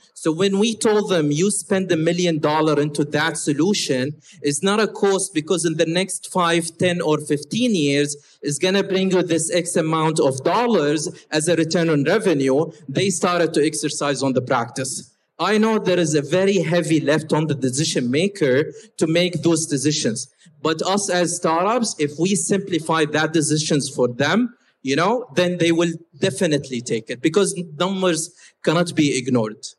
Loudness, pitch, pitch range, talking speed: -20 LUFS, 165 Hz, 150-185 Hz, 175 wpm